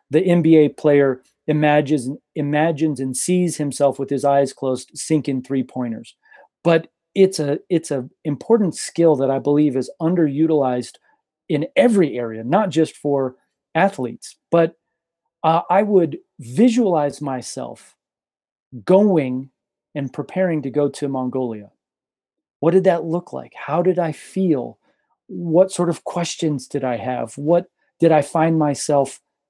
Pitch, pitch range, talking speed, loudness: 150 Hz, 135-170 Hz, 140 wpm, -19 LUFS